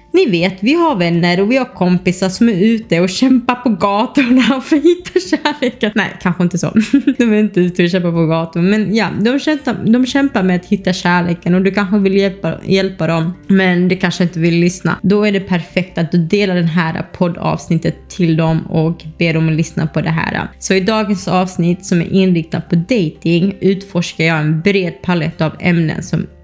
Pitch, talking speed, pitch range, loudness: 185 Hz, 205 wpm, 170-210 Hz, -14 LUFS